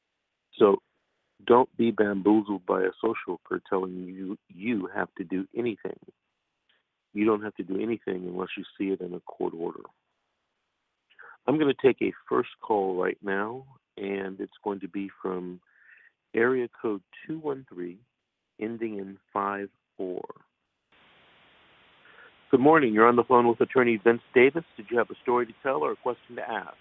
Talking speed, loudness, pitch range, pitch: 165 wpm, -27 LUFS, 95-115 Hz, 100 Hz